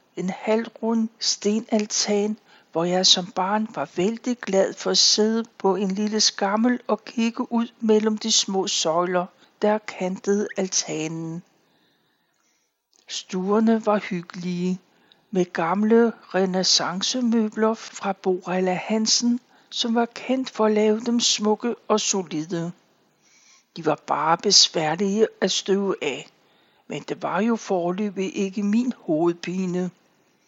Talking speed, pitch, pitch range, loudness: 120 wpm, 205 Hz, 185-225 Hz, -22 LUFS